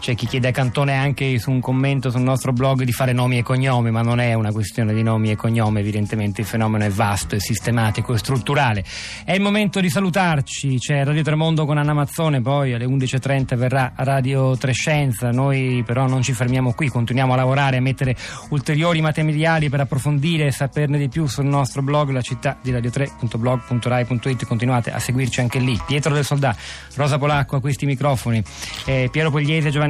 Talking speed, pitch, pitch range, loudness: 190 wpm, 130 Hz, 120-145 Hz, -20 LUFS